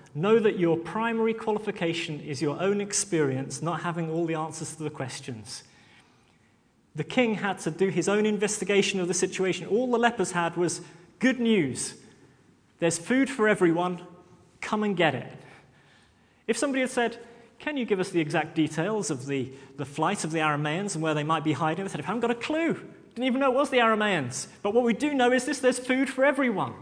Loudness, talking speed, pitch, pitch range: -27 LUFS, 205 wpm, 180 Hz, 155-225 Hz